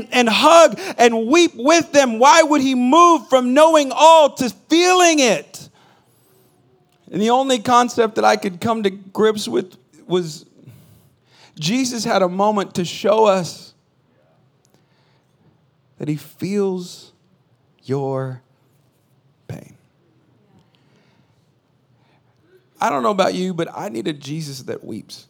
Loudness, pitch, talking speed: -16 LUFS, 195 Hz, 125 wpm